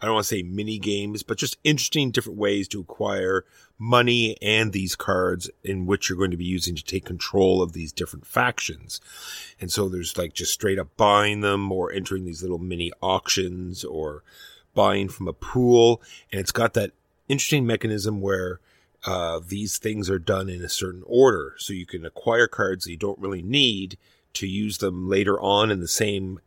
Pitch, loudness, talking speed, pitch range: 95 Hz, -24 LUFS, 195 wpm, 90-105 Hz